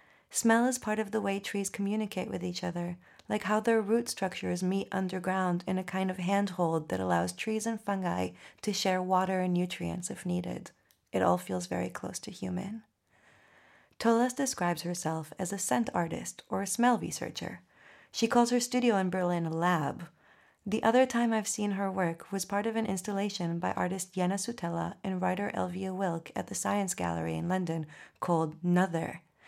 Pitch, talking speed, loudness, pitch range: 190 Hz, 180 wpm, -31 LUFS, 175-210 Hz